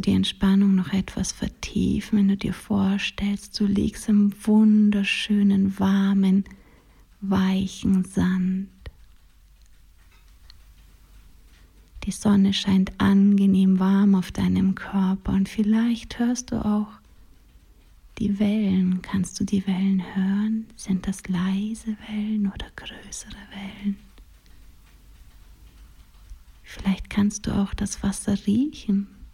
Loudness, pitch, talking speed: -23 LUFS, 195 Hz, 100 wpm